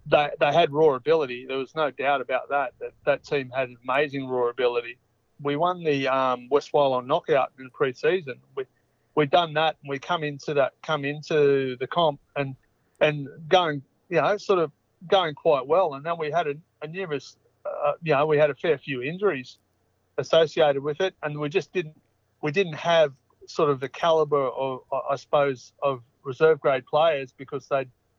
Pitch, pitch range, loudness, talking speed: 145 Hz, 130-165 Hz, -25 LUFS, 190 wpm